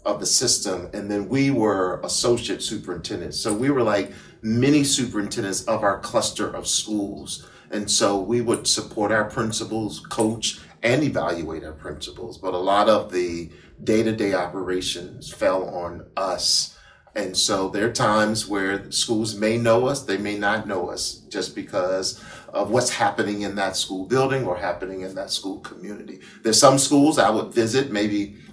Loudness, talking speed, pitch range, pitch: -22 LUFS, 170 wpm, 100-115 Hz, 105 Hz